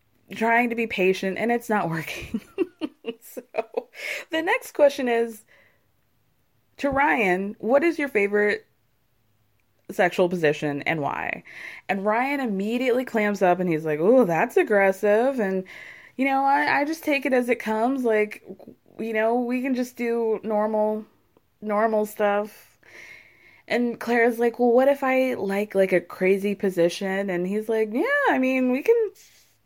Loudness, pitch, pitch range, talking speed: -23 LUFS, 225 Hz, 195-255 Hz, 150 wpm